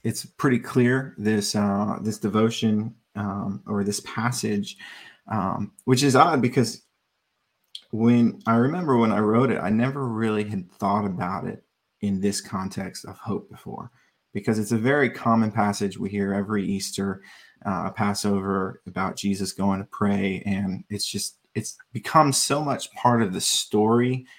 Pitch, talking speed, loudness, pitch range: 105 Hz, 155 wpm, -24 LUFS, 100-120 Hz